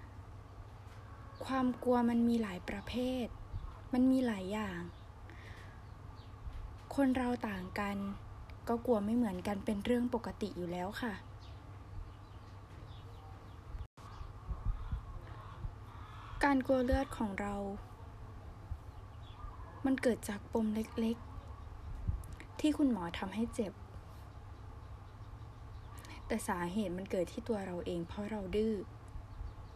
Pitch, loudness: 105 Hz, -37 LUFS